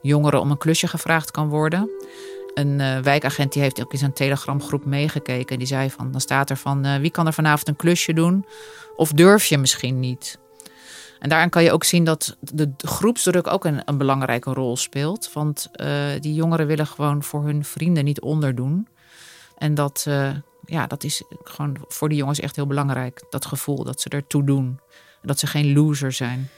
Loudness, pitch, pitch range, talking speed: -21 LUFS, 145 Hz, 140-160 Hz, 200 wpm